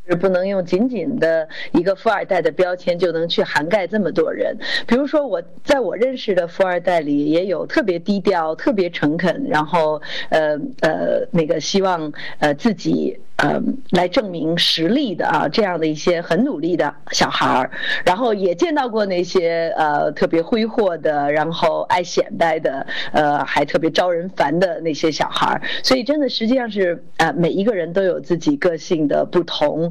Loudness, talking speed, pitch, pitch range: -19 LUFS, 265 characters per minute, 180 Hz, 160-225 Hz